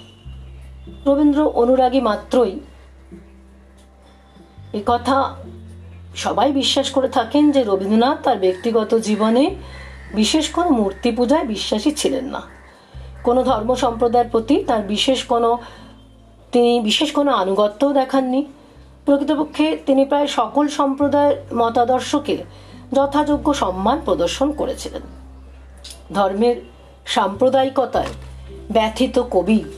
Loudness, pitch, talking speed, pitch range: -18 LUFS, 240 Hz, 95 wpm, 180-275 Hz